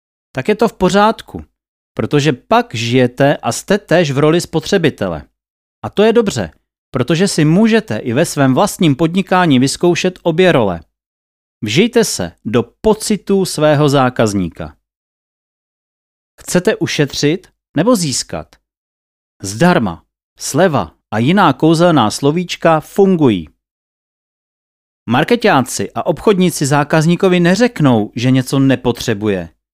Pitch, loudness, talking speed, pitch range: 150 Hz, -13 LUFS, 110 wpm, 115-185 Hz